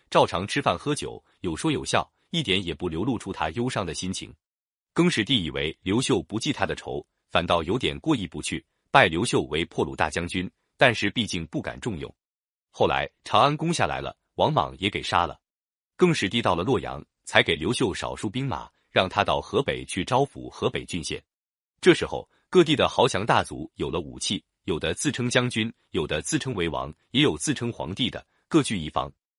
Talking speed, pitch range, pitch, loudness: 280 characters per minute, 80-135 Hz, 110 Hz, -25 LUFS